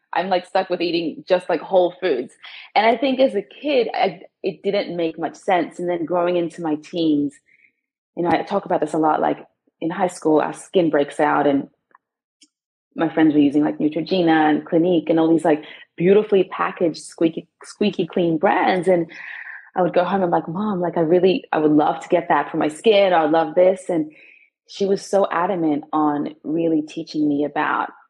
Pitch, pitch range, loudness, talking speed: 170 Hz, 160-185 Hz, -20 LUFS, 205 wpm